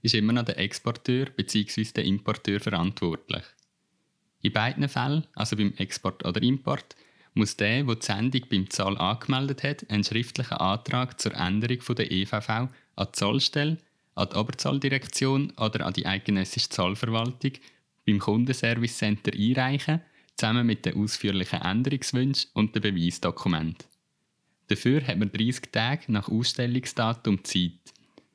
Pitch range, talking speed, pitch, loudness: 100-130 Hz, 130 wpm, 115 Hz, -27 LUFS